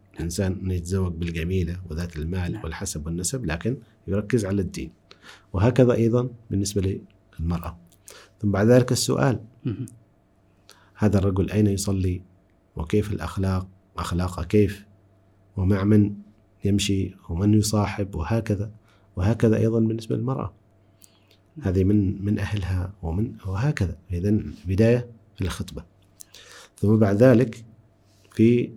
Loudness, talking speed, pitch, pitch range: -24 LUFS, 110 wpm, 100 Hz, 95-110 Hz